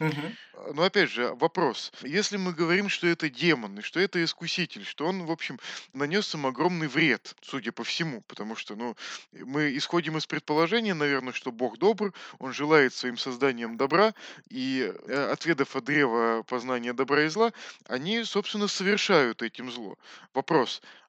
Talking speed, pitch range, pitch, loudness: 155 wpm, 135-195 Hz, 160 Hz, -27 LUFS